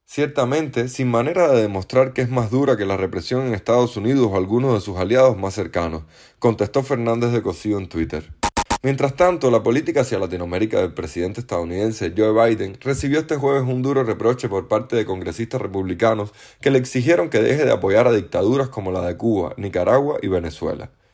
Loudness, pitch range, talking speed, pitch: -20 LUFS, 95-130 Hz, 185 wpm, 115 Hz